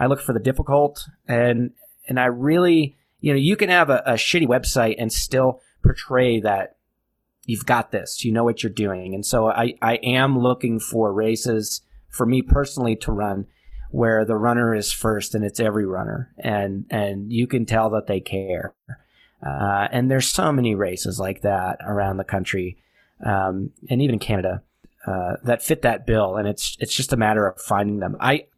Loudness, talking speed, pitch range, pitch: -21 LUFS, 190 wpm, 100-130 Hz, 115 Hz